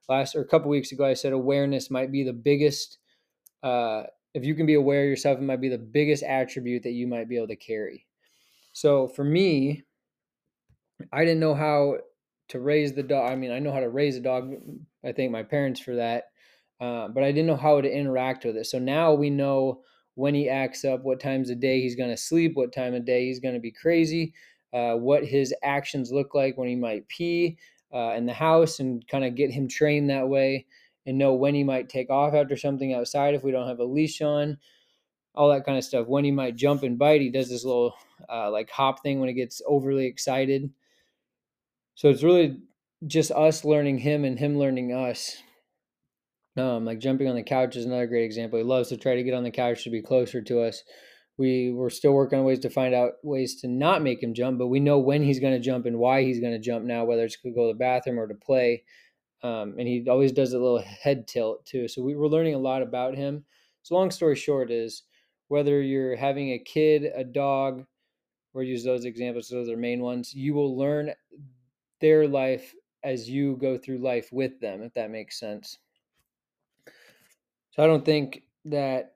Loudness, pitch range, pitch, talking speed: -25 LUFS, 125-145 Hz, 135 Hz, 220 wpm